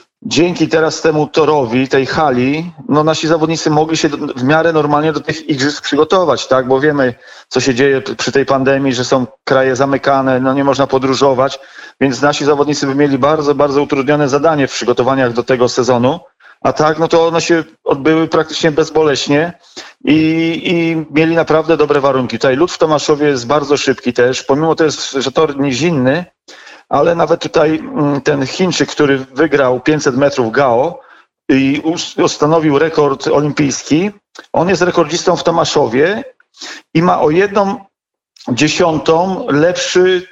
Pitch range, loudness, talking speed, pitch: 135-160 Hz, -13 LUFS, 155 wpm, 150 Hz